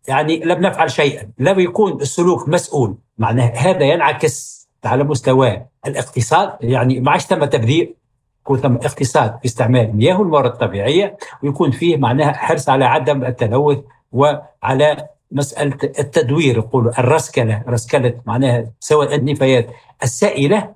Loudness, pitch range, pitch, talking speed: -16 LUFS, 125-150 Hz, 140 Hz, 120 wpm